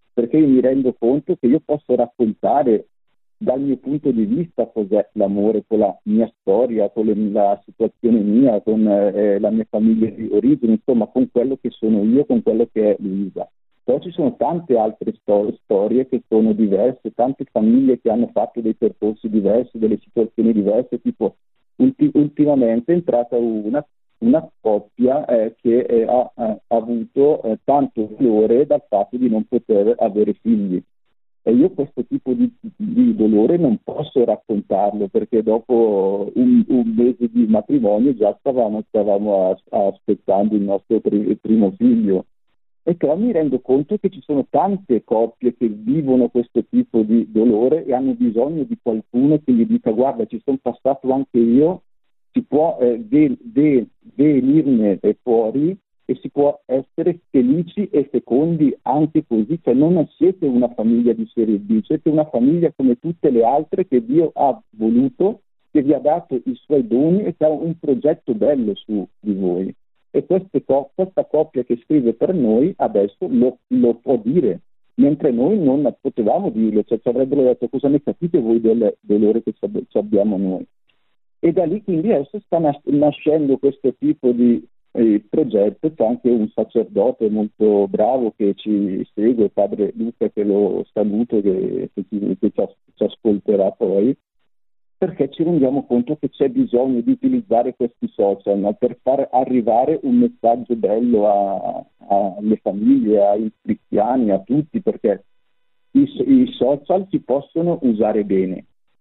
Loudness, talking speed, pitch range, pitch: -18 LUFS, 160 wpm, 110-155 Hz, 125 Hz